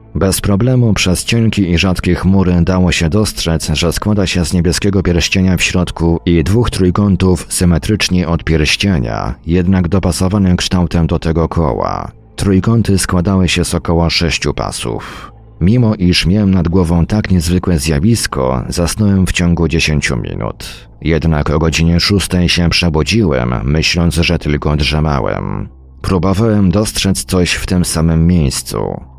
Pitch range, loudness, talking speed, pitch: 80-95 Hz, -13 LUFS, 140 wpm, 90 Hz